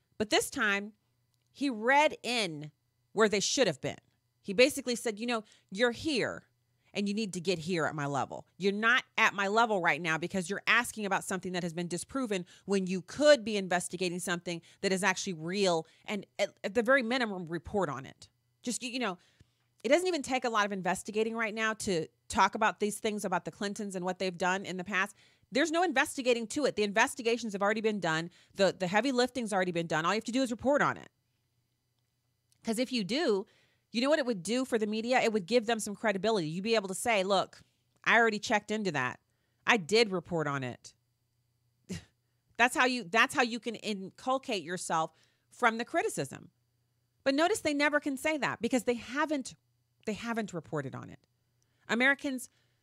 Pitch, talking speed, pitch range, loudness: 200 Hz, 205 wpm, 165-235 Hz, -31 LUFS